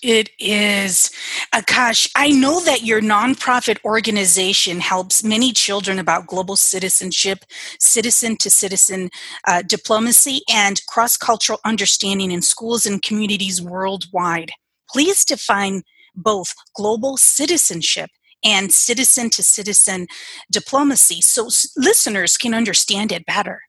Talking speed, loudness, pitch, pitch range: 115 wpm, -15 LUFS, 210 Hz, 190-235 Hz